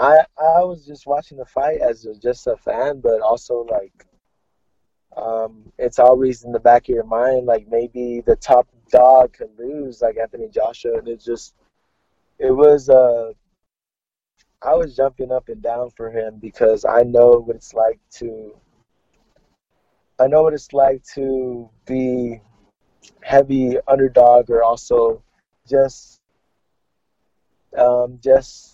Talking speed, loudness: 145 wpm, -17 LUFS